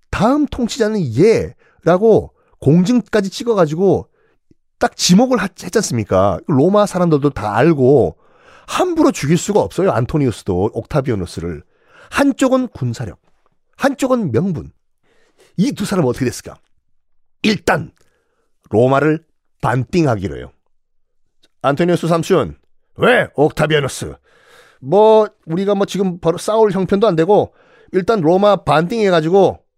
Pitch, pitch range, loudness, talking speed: 185 Hz, 150-225 Hz, -15 LUFS, 270 characters per minute